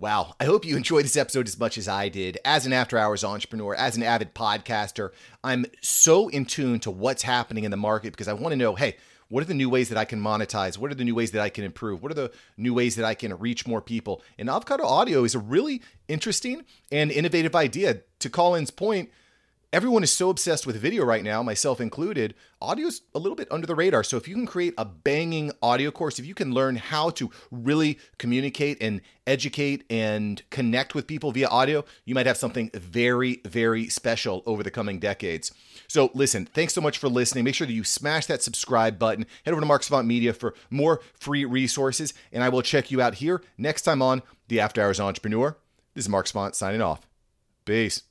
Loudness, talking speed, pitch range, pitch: -25 LUFS, 220 wpm, 110-145 Hz, 125 Hz